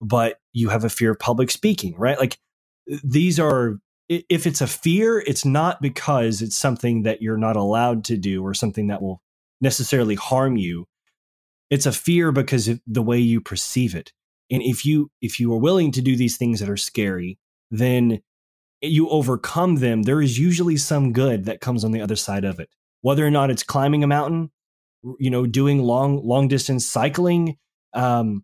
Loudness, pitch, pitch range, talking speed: -21 LUFS, 125 Hz, 110-145 Hz, 190 wpm